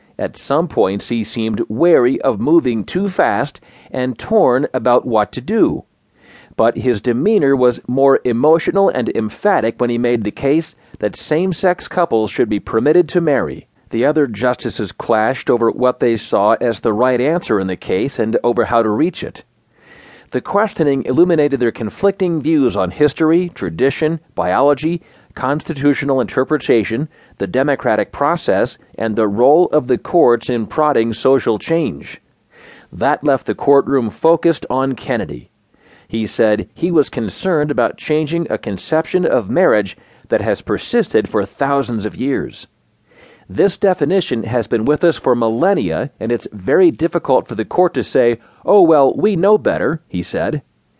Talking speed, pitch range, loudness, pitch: 155 wpm, 115-165 Hz, -16 LUFS, 135 Hz